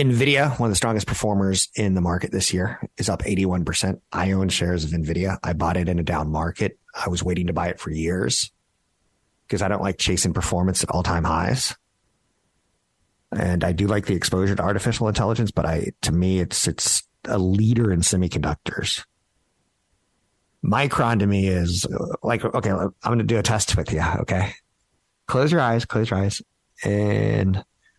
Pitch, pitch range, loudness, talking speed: 95 Hz, 90-110 Hz, -22 LUFS, 180 wpm